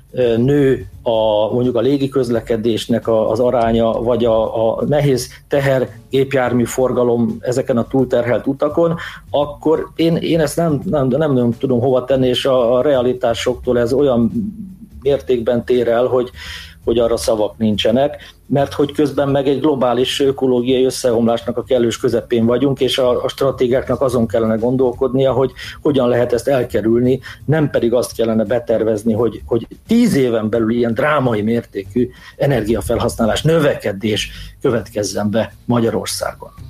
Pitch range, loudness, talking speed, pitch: 115-135 Hz, -16 LUFS, 135 wpm, 125 Hz